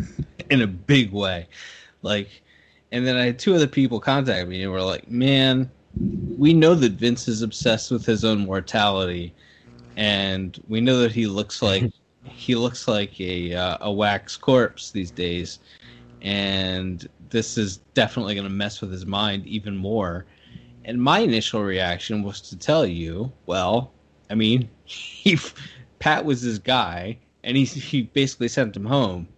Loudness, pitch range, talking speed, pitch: -22 LUFS, 95-125 Hz, 165 wpm, 105 Hz